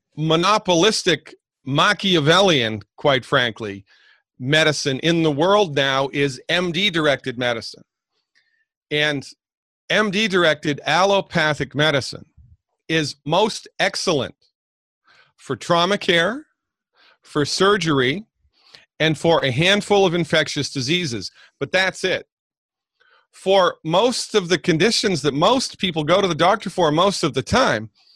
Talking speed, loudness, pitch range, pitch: 115 wpm, -19 LUFS, 145-195 Hz, 165 Hz